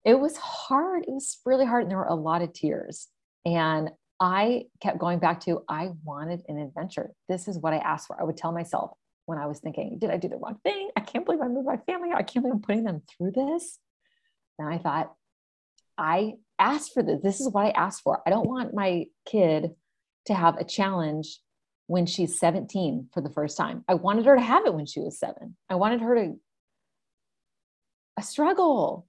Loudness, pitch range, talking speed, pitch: -27 LUFS, 165-245 Hz, 215 wpm, 190 Hz